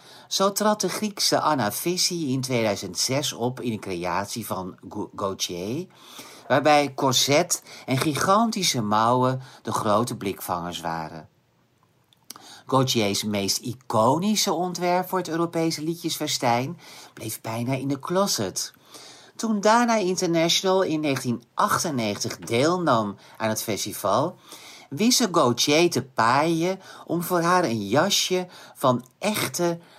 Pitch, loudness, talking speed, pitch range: 145 Hz, -23 LUFS, 115 wpm, 115-180 Hz